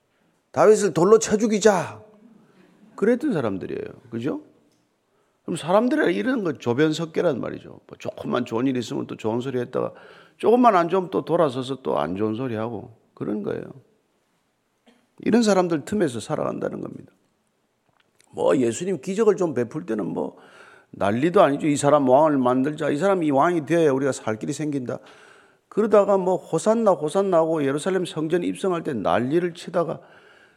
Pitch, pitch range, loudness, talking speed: 170 Hz, 135-195 Hz, -22 LUFS, 330 characters per minute